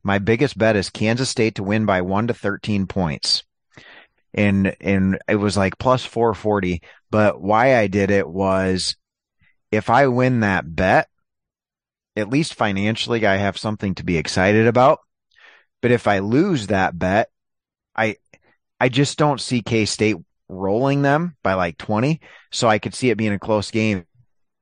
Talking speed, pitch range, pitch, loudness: 165 wpm, 95-120 Hz, 105 Hz, -19 LUFS